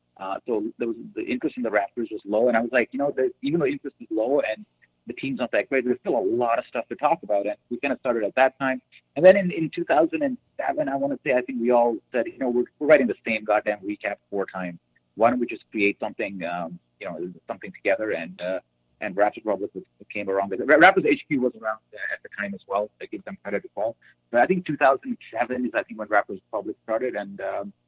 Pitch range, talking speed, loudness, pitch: 105-135 Hz, 270 wpm, -24 LUFS, 115 Hz